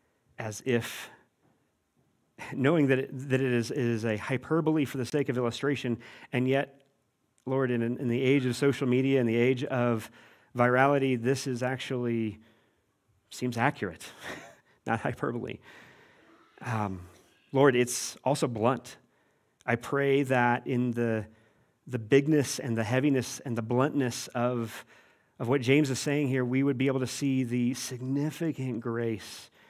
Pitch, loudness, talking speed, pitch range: 125 Hz, -29 LUFS, 145 wpm, 120-135 Hz